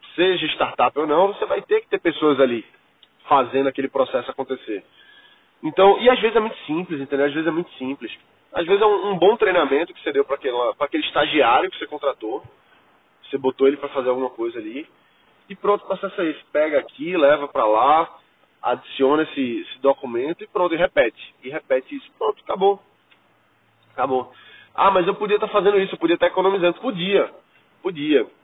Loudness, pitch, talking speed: -20 LUFS, 195 Hz, 195 wpm